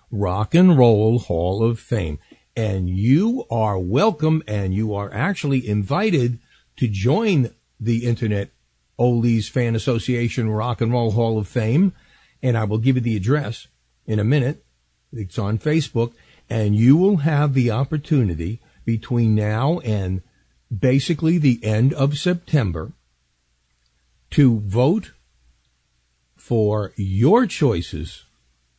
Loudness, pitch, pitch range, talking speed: -20 LUFS, 115 Hz, 95-135 Hz, 125 wpm